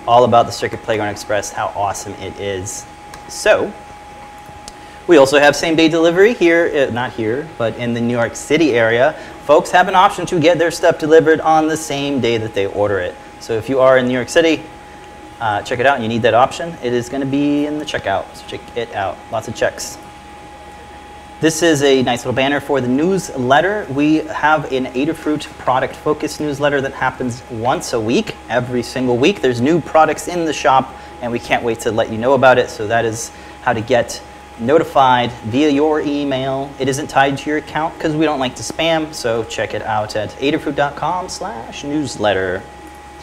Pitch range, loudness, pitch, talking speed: 120-155 Hz, -16 LUFS, 135 Hz, 195 wpm